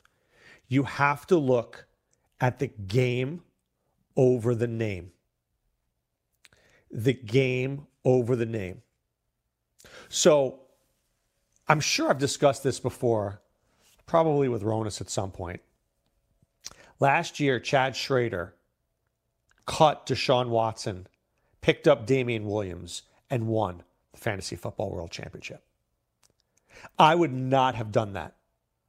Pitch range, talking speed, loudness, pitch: 100-135 Hz, 110 wpm, -26 LUFS, 120 Hz